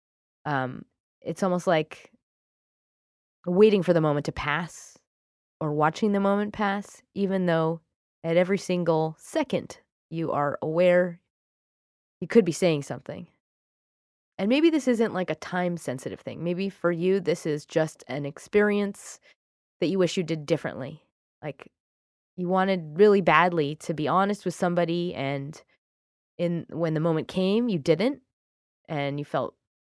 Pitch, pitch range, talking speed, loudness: 170 Hz, 150-190 Hz, 145 wpm, -26 LUFS